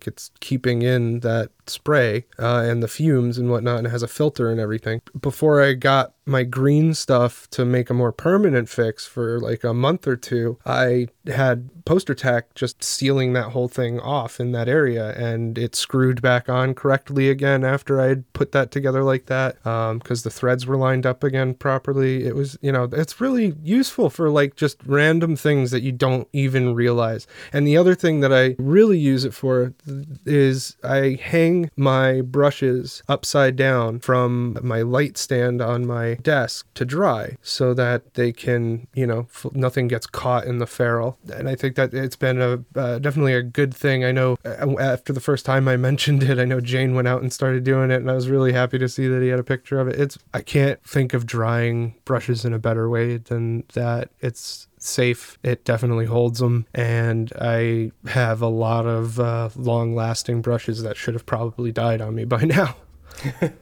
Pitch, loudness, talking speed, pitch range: 125 Hz, -21 LUFS, 200 wpm, 120-135 Hz